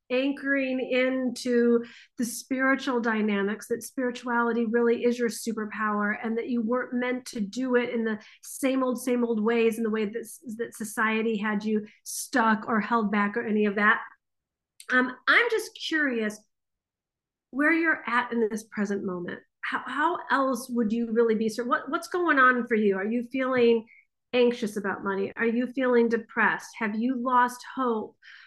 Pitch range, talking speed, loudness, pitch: 220-255 Hz, 170 wpm, -26 LUFS, 235 Hz